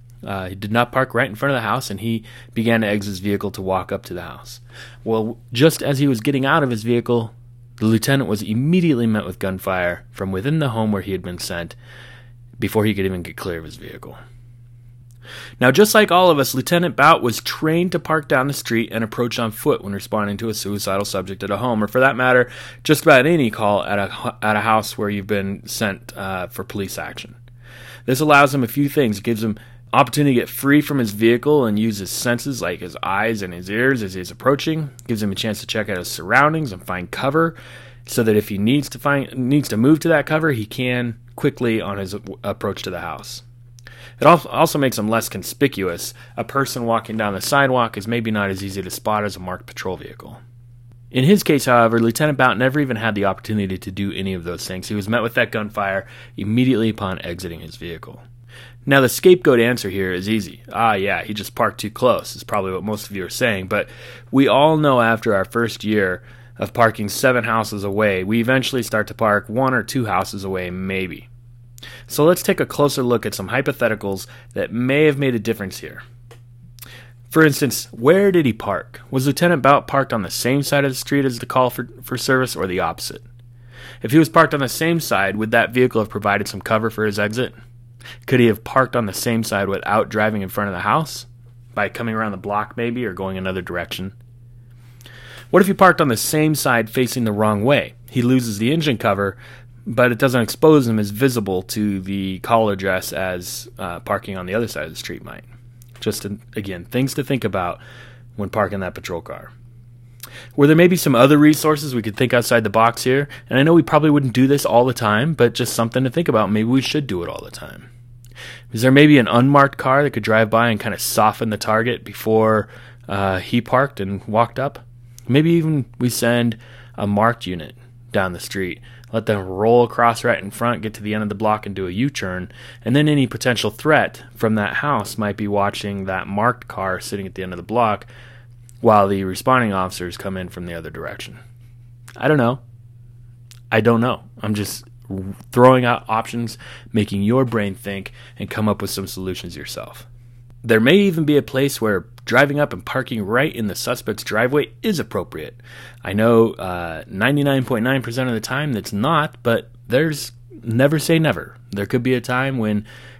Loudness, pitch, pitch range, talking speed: -19 LUFS, 120 Hz, 105-130 Hz, 215 wpm